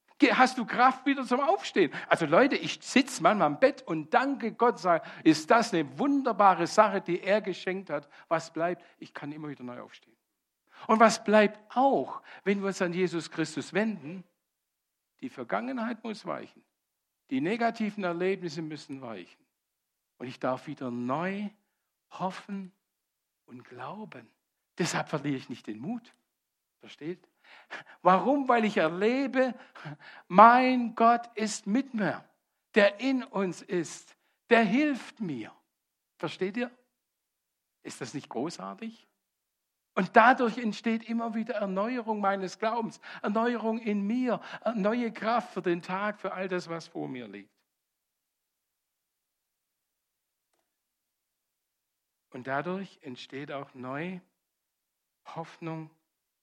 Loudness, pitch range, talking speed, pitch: -28 LUFS, 170-235 Hz, 130 wpm, 200 Hz